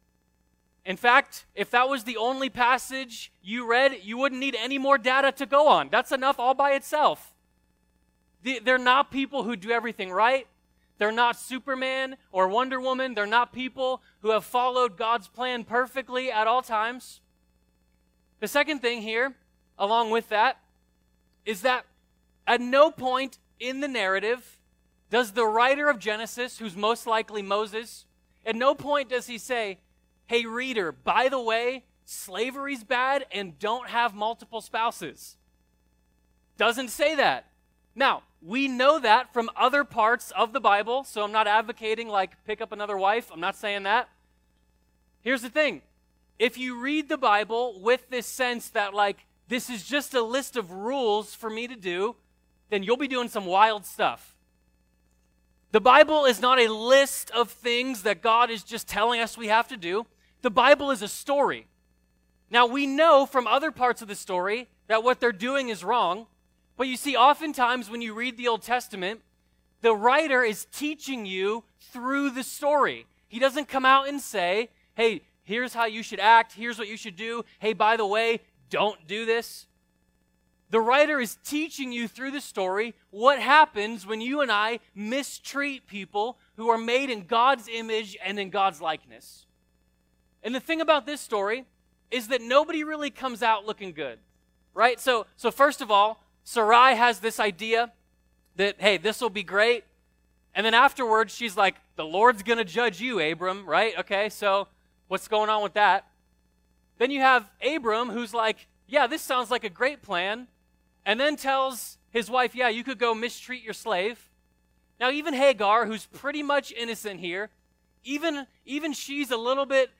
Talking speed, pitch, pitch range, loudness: 170 wpm, 230 Hz, 200-255 Hz, -25 LUFS